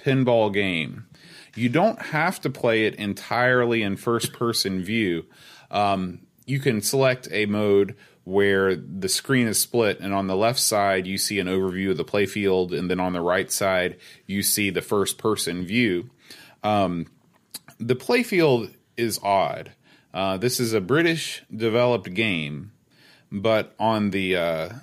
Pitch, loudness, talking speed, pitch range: 105 Hz, -23 LUFS, 160 wpm, 95-120 Hz